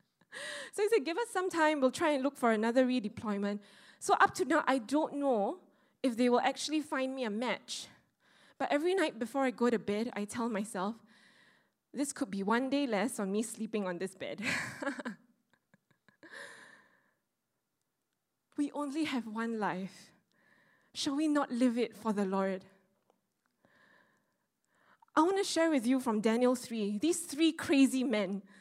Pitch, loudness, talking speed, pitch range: 255 Hz, -33 LUFS, 165 wpm, 215-290 Hz